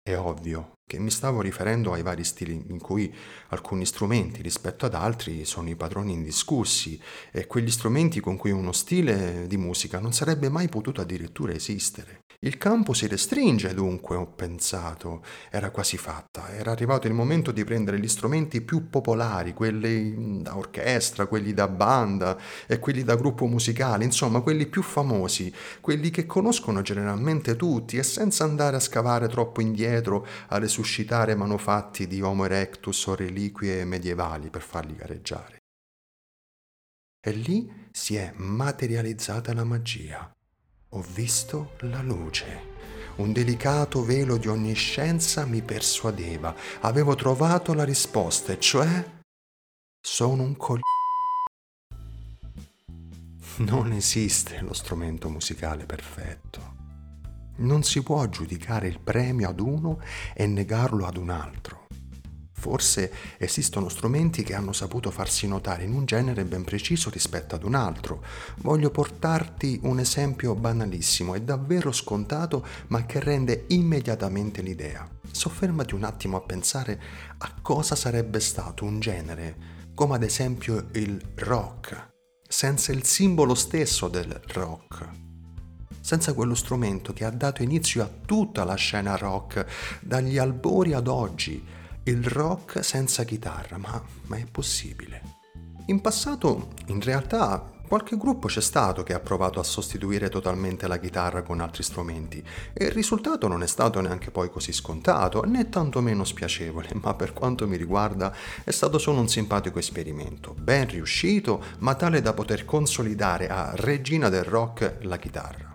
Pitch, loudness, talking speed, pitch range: 110 Hz, -26 LUFS, 140 wpm, 90-130 Hz